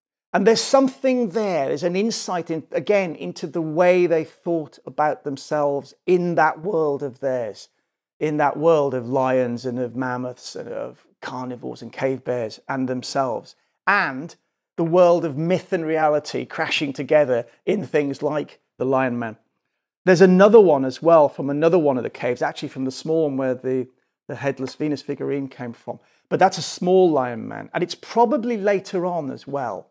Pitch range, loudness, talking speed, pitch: 130-180 Hz, -21 LUFS, 180 wpm, 150 Hz